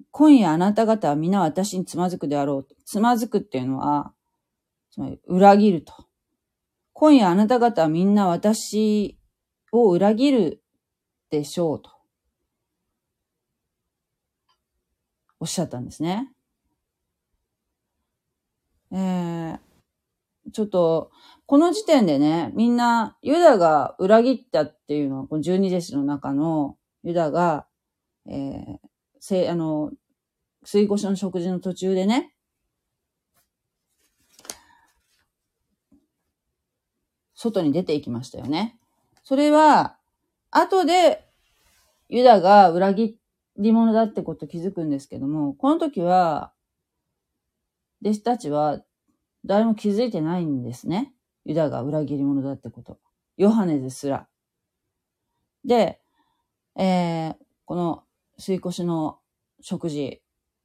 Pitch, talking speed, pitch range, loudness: 185 Hz, 210 characters per minute, 155-230 Hz, -21 LUFS